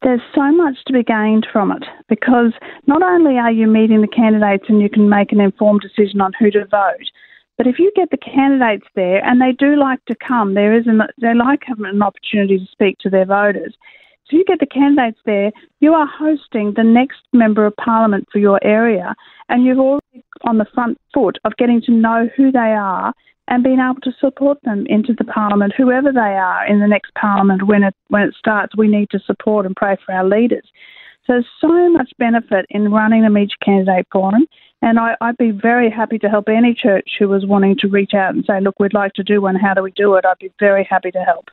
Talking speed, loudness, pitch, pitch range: 230 wpm, -14 LUFS, 220 Hz, 205-250 Hz